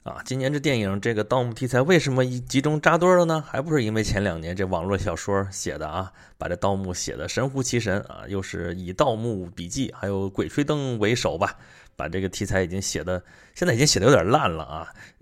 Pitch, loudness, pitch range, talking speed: 105 Hz, -24 LUFS, 95-135 Hz, 330 characters per minute